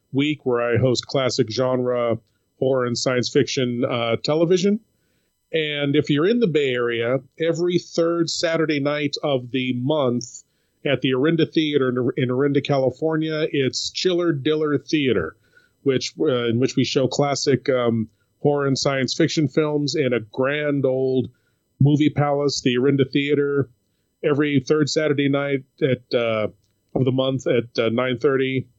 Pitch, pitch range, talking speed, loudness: 135 Hz, 125-150 Hz, 150 wpm, -21 LUFS